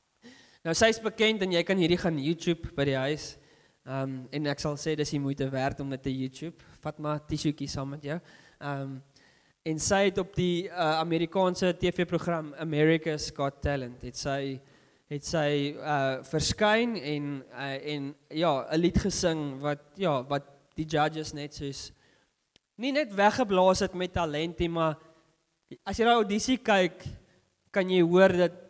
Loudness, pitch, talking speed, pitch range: -28 LUFS, 155 Hz, 180 wpm, 140-180 Hz